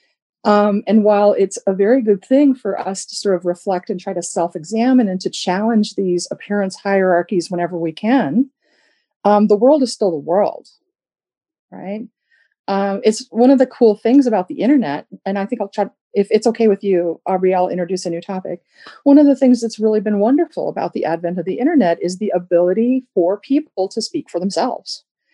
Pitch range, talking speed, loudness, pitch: 185-250 Hz, 200 wpm, -16 LUFS, 205 Hz